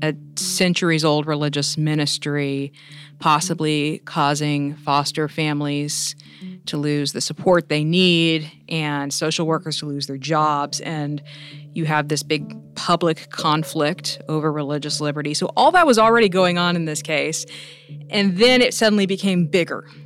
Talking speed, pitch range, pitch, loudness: 145 wpm, 145-165 Hz, 150 Hz, -20 LUFS